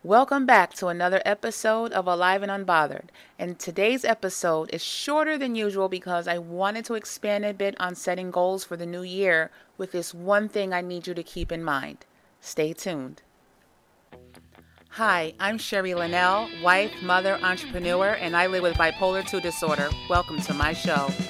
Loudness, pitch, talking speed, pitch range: -25 LUFS, 180 Hz, 170 wpm, 175-200 Hz